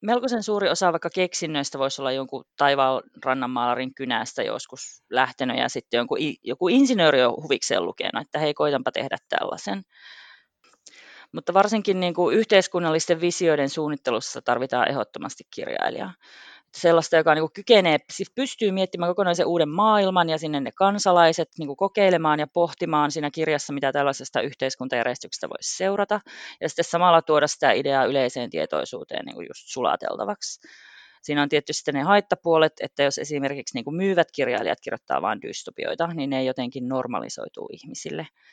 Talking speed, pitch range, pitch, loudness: 140 wpm, 140-190 Hz, 160 Hz, -23 LUFS